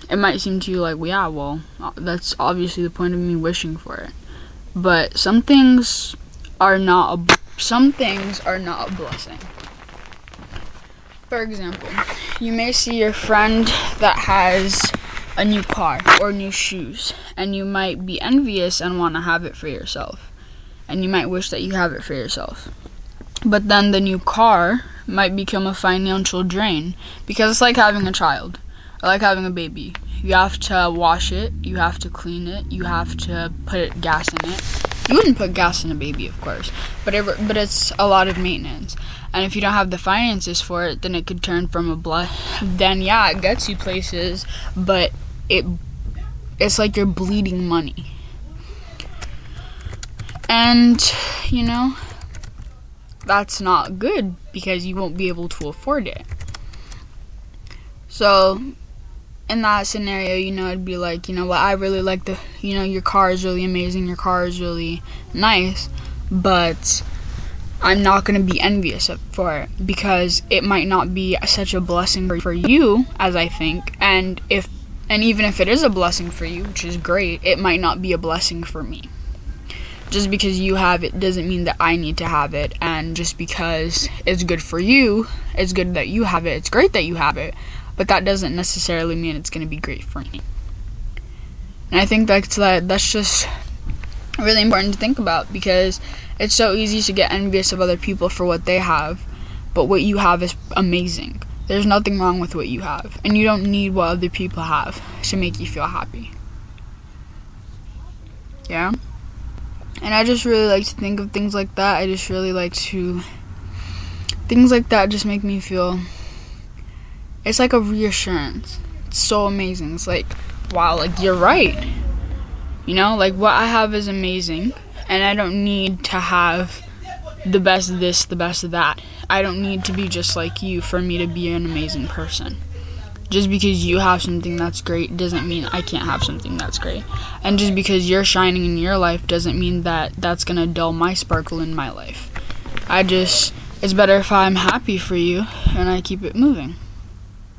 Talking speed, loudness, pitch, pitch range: 185 wpm, -18 LUFS, 180 Hz, 155-195 Hz